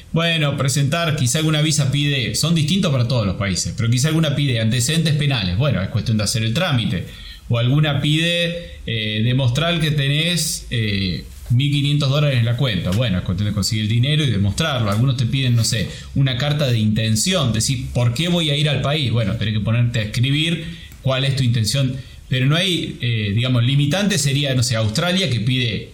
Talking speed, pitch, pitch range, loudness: 200 wpm, 130 Hz, 115-150 Hz, -18 LUFS